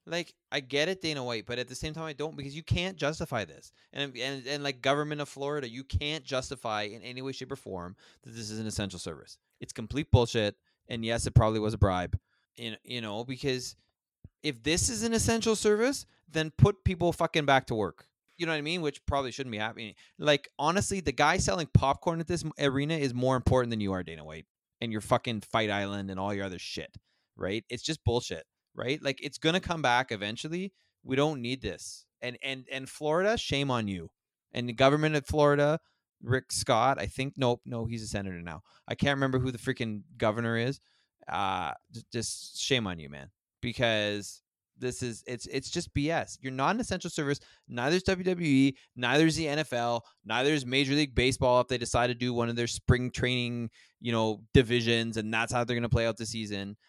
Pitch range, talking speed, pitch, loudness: 115-145 Hz, 210 wpm, 125 Hz, -30 LUFS